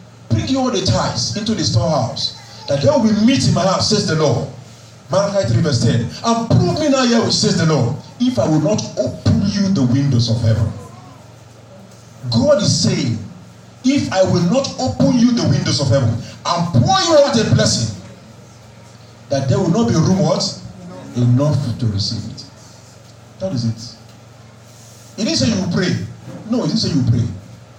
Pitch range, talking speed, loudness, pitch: 115-175 Hz, 205 wpm, -16 LUFS, 125 Hz